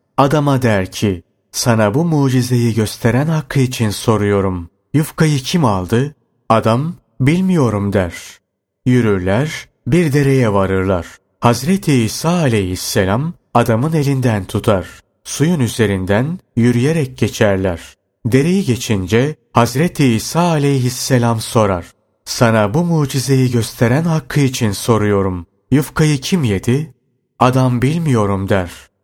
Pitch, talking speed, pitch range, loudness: 120 Hz, 100 wpm, 105-140 Hz, -15 LUFS